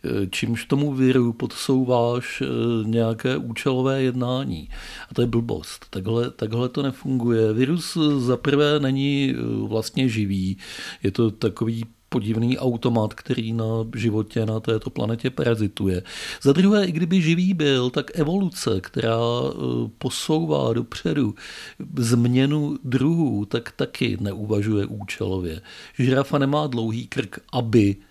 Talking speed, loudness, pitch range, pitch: 115 wpm, -23 LUFS, 110-135 Hz, 120 Hz